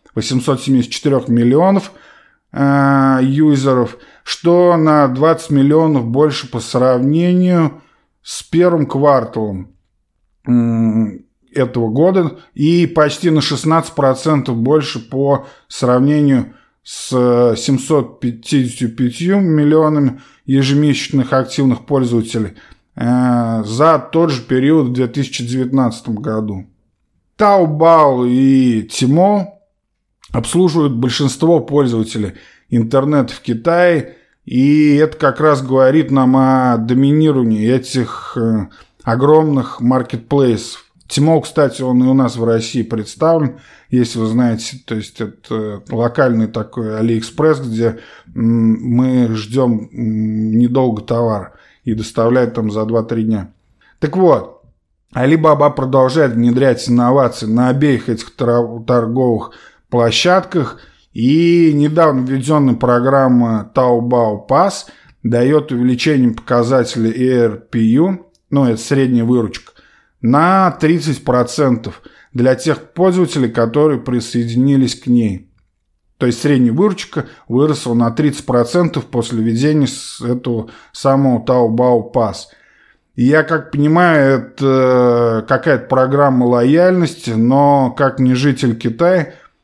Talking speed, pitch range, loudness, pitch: 100 wpm, 115-150 Hz, -14 LUFS, 130 Hz